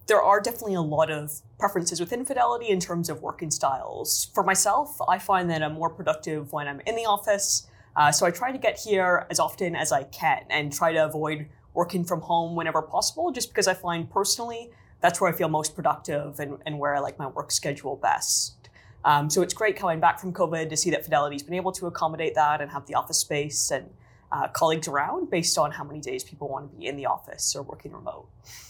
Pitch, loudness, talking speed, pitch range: 170 Hz, -26 LUFS, 230 wpm, 150-190 Hz